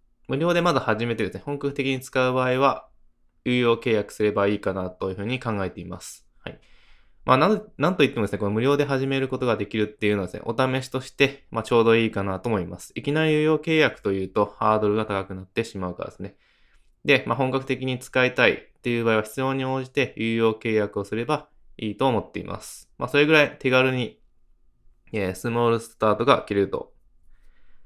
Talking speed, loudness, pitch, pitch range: 425 characters per minute, -23 LUFS, 120 Hz, 105-135 Hz